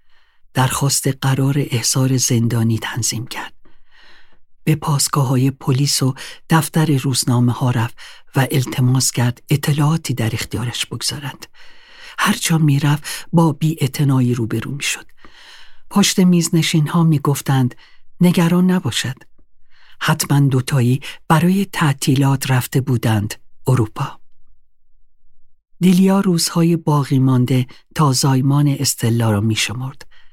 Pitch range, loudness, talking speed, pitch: 125-160 Hz, -17 LUFS, 105 wpm, 140 Hz